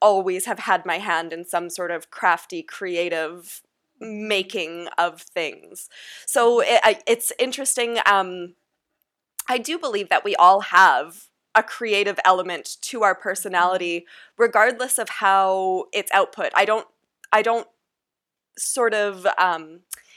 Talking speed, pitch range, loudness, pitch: 130 wpm, 180-235 Hz, -21 LUFS, 200 Hz